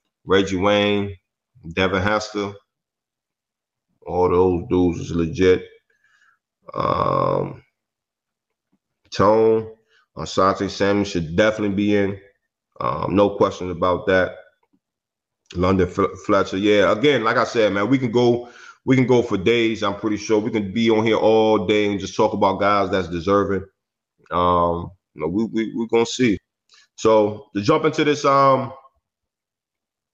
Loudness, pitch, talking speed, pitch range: -19 LUFS, 100 Hz, 140 wpm, 95-110 Hz